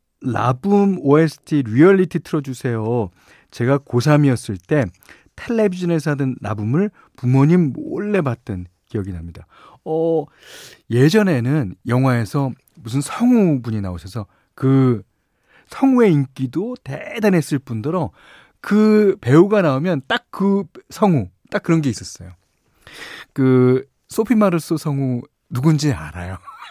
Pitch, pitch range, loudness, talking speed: 140 Hz, 120-175 Hz, -18 LUFS, 250 characters per minute